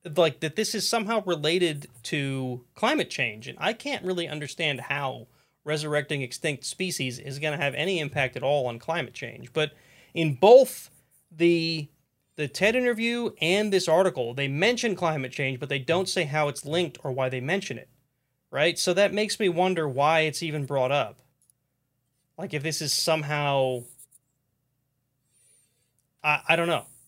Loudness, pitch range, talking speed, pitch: -26 LUFS, 135-175 Hz, 165 wpm, 150 Hz